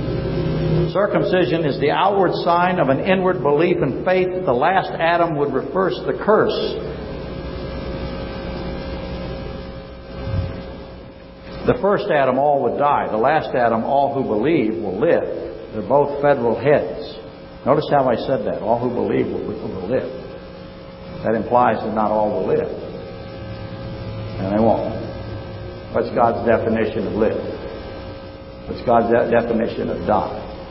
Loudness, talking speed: -19 LUFS, 135 wpm